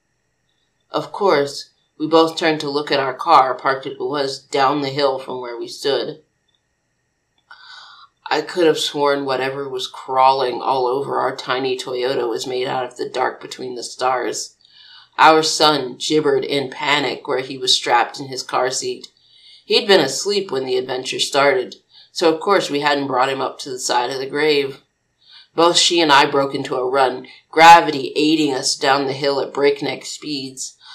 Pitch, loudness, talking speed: 150 Hz, -17 LUFS, 180 wpm